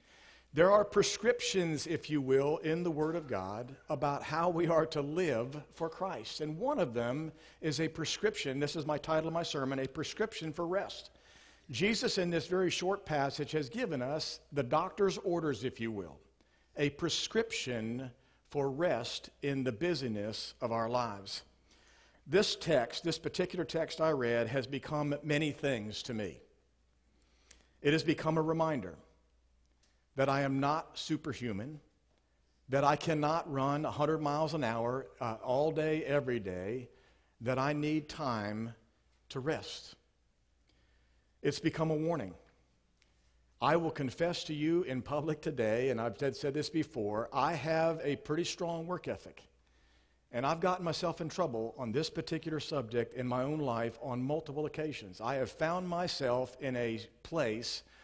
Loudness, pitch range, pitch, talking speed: -35 LUFS, 115-160 Hz, 145 Hz, 160 wpm